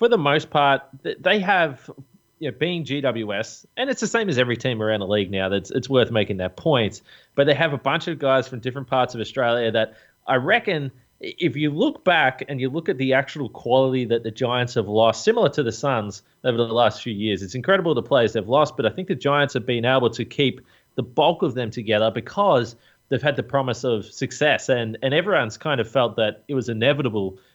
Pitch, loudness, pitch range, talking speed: 130 Hz, -22 LUFS, 115-145 Hz, 230 wpm